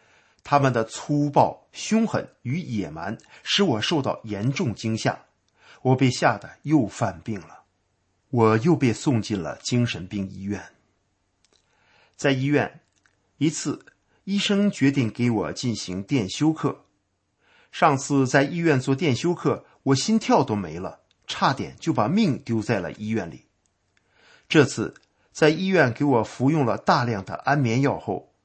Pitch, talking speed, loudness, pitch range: 130 Hz, 205 characters per minute, -23 LUFS, 110-145 Hz